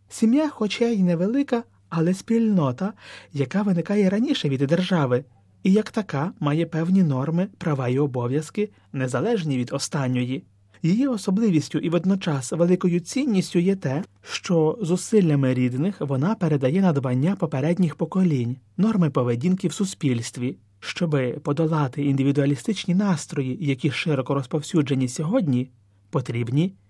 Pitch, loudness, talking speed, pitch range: 160 Hz, -23 LUFS, 115 wpm, 135-190 Hz